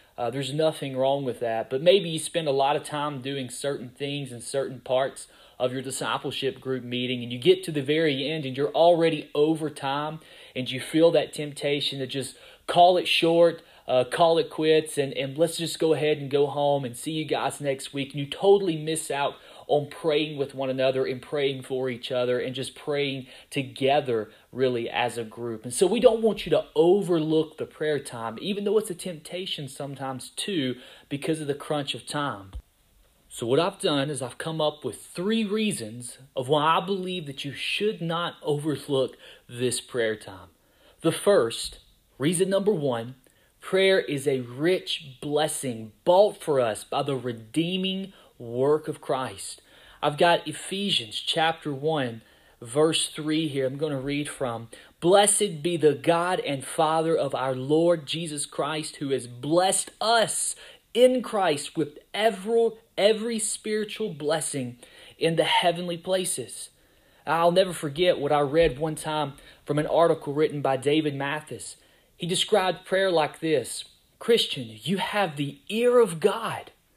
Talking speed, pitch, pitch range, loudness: 170 wpm, 150 Hz, 130-170 Hz, -25 LUFS